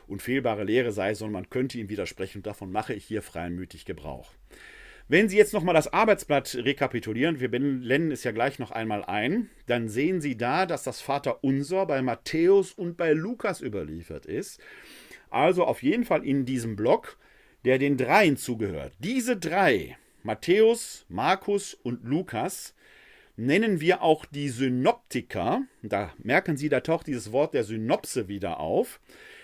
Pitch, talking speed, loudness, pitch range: 140 Hz, 155 wpm, -26 LUFS, 115-190 Hz